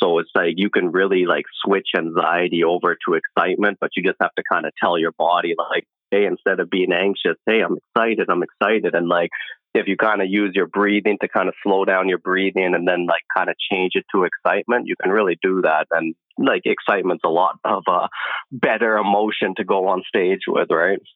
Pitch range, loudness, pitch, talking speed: 90-100 Hz, -19 LUFS, 95 Hz, 220 wpm